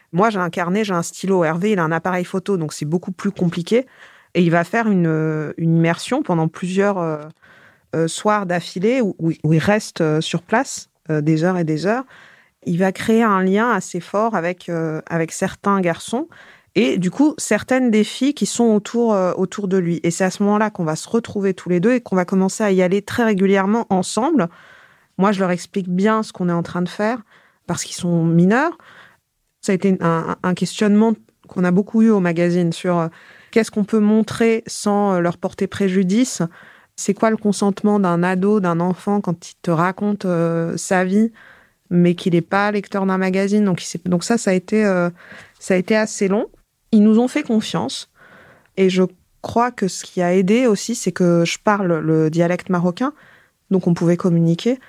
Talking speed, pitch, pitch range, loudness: 205 wpm, 190 Hz, 175-215 Hz, -18 LUFS